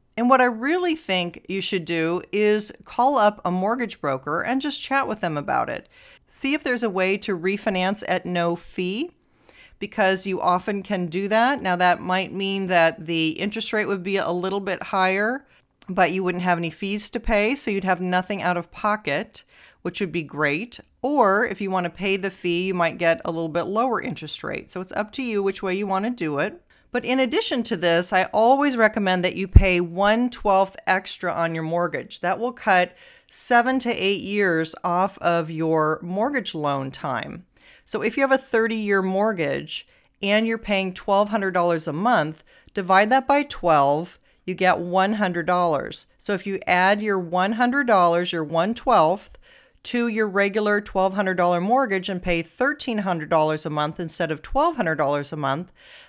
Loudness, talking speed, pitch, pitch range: -22 LUFS, 185 wpm, 195 Hz, 175-220 Hz